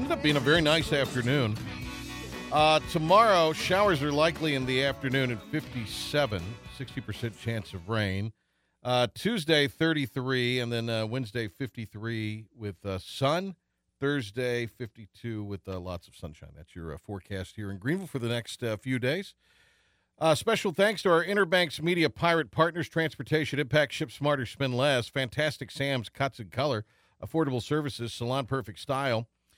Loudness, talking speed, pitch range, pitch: -28 LUFS, 155 wpm, 110-155 Hz, 130 Hz